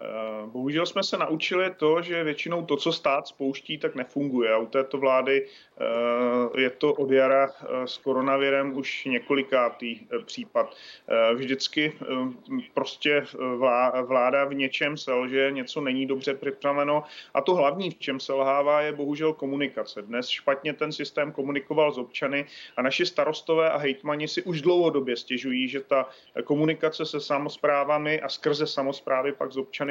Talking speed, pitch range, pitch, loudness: 140 wpm, 130-150 Hz, 140 Hz, -26 LUFS